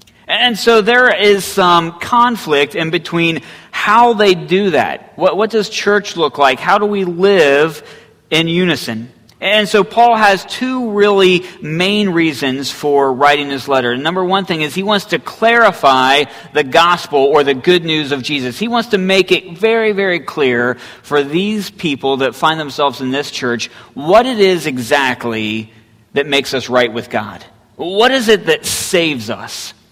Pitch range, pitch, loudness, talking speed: 135-200 Hz, 165 Hz, -13 LUFS, 170 wpm